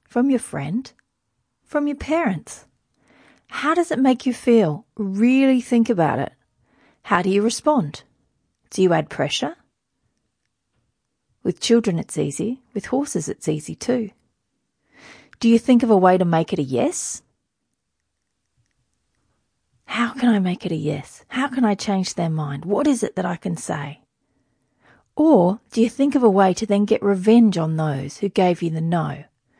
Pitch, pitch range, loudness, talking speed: 205 Hz, 160-245 Hz, -20 LUFS, 165 wpm